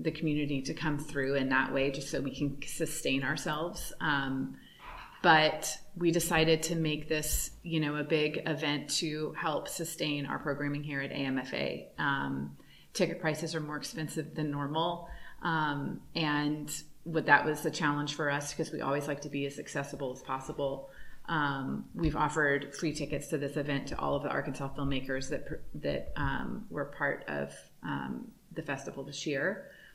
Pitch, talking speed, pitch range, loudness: 150 Hz, 170 wpm, 140-160 Hz, -33 LUFS